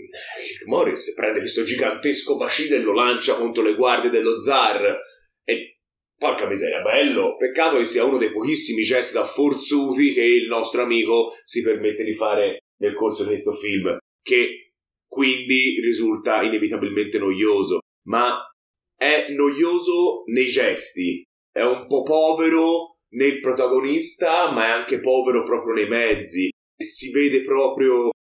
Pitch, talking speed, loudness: 355 Hz, 140 wpm, -20 LUFS